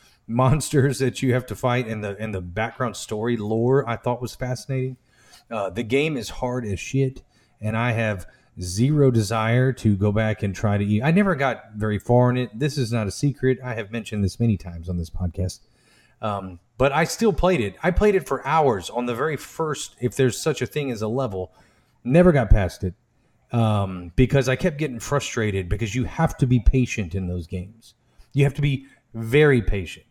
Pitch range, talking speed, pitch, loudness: 105-135 Hz, 210 wpm, 120 Hz, -23 LUFS